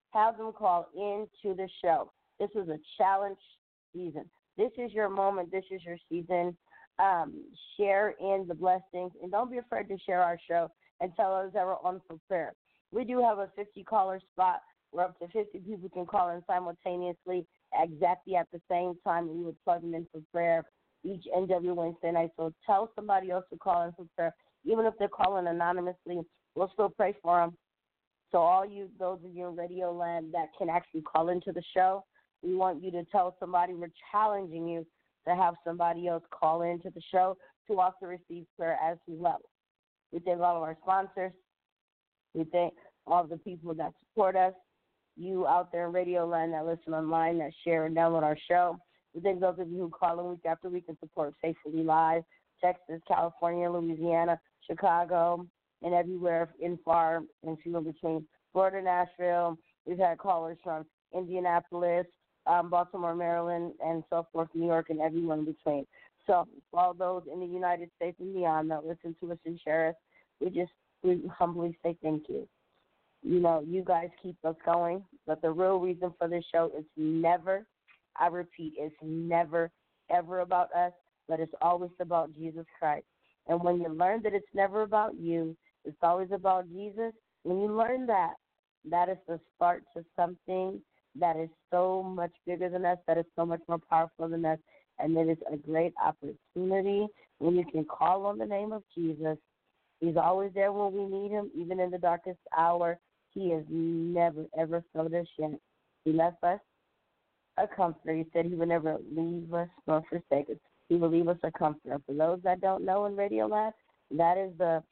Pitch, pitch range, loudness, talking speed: 175 Hz, 165-185 Hz, -31 LUFS, 190 wpm